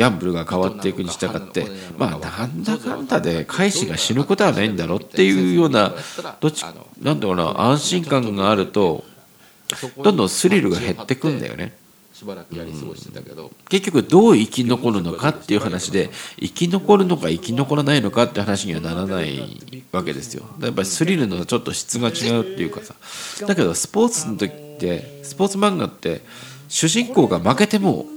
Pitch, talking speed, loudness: 130 Hz, 370 characters per minute, -20 LUFS